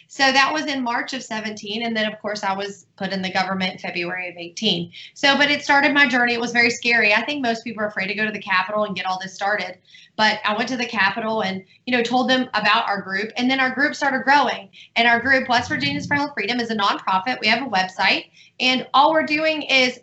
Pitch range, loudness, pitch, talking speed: 195-260 Hz, -19 LUFS, 225 Hz, 260 wpm